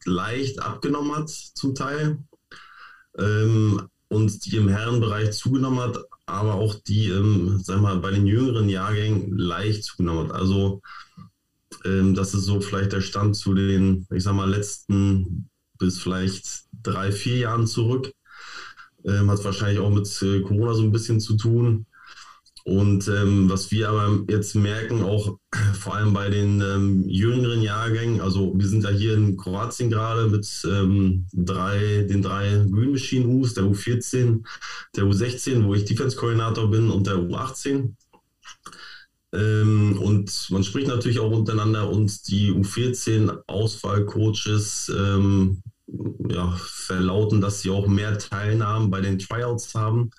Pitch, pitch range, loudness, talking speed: 105 Hz, 100-110 Hz, -23 LUFS, 145 wpm